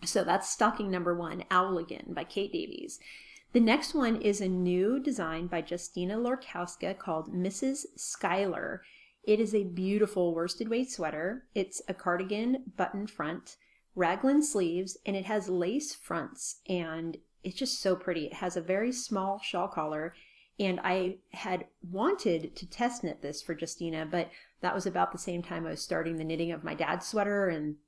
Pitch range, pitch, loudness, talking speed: 175-220 Hz, 185 Hz, -32 LUFS, 170 wpm